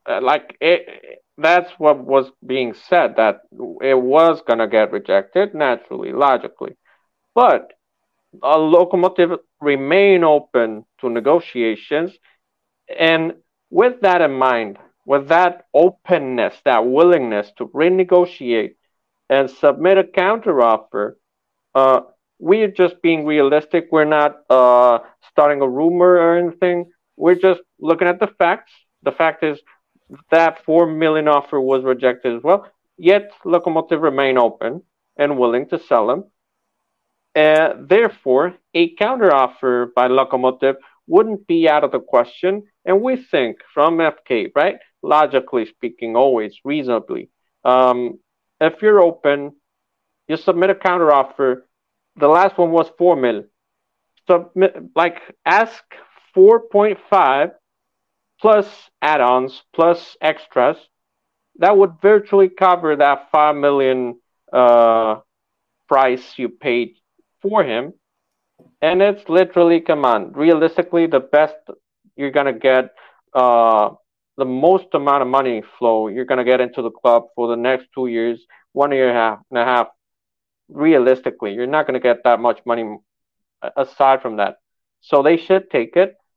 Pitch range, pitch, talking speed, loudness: 130-175 Hz, 150 Hz, 135 wpm, -16 LUFS